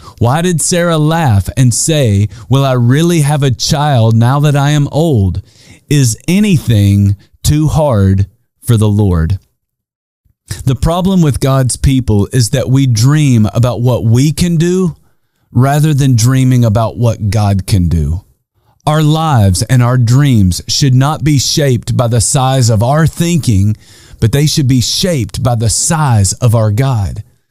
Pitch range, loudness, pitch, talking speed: 110-145 Hz, -11 LUFS, 125 Hz, 155 wpm